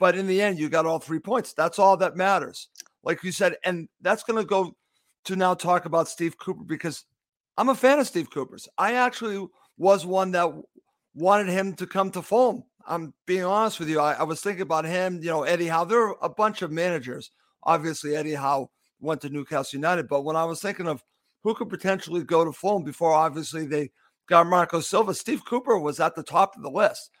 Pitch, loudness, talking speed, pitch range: 175 Hz, -25 LUFS, 220 wpm, 160-195 Hz